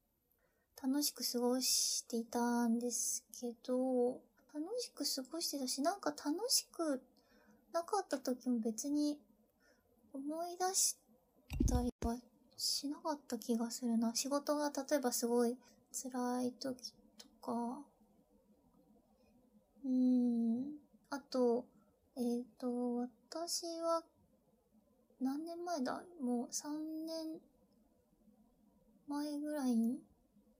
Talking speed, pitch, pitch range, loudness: 175 characters per minute, 250 Hz, 240-295 Hz, -38 LUFS